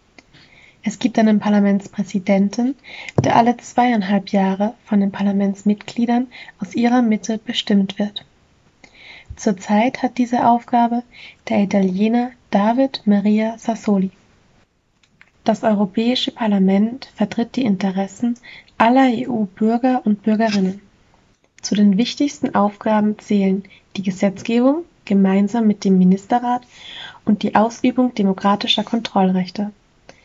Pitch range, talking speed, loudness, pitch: 200-240 Hz, 100 wpm, -18 LUFS, 215 Hz